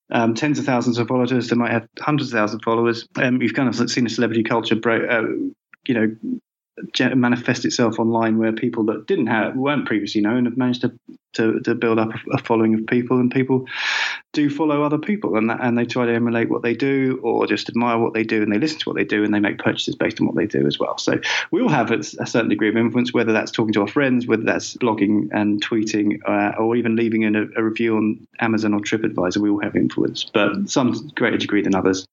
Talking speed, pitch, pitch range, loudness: 245 wpm, 115 Hz, 110-125 Hz, -20 LUFS